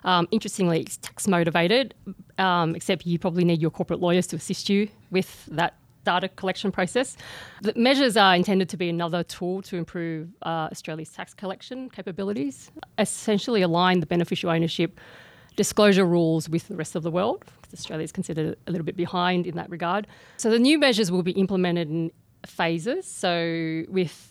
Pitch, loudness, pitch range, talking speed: 180 Hz, -24 LUFS, 170-195 Hz, 175 wpm